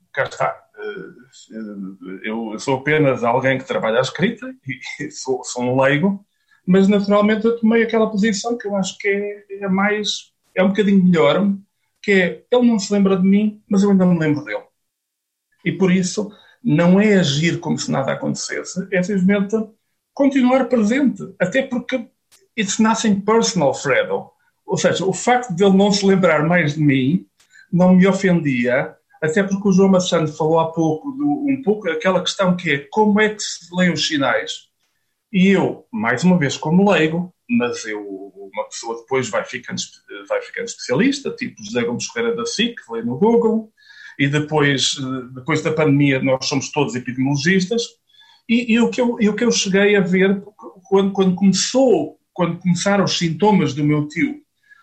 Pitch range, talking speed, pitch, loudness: 155-225 Hz, 175 wpm, 195 Hz, -18 LUFS